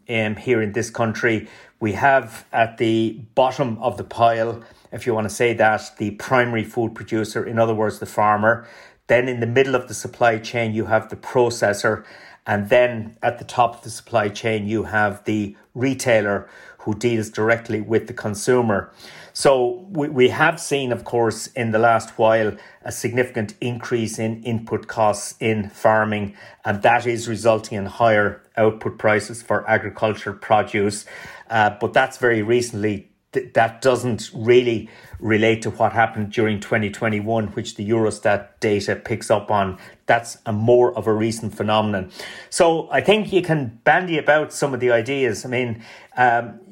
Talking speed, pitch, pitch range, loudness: 165 wpm, 115 Hz, 110-120 Hz, -20 LUFS